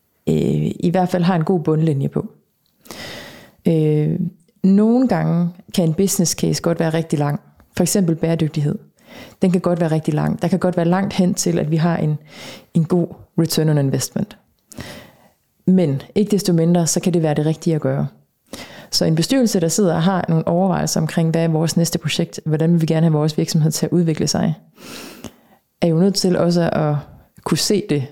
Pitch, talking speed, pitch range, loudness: 170 Hz, 195 wpm, 160-185 Hz, -18 LUFS